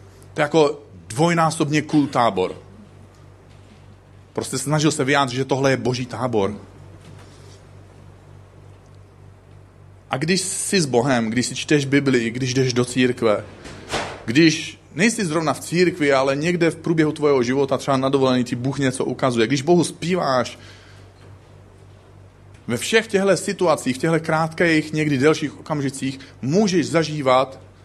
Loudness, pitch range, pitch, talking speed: -20 LUFS, 100-155 Hz, 130 Hz, 130 wpm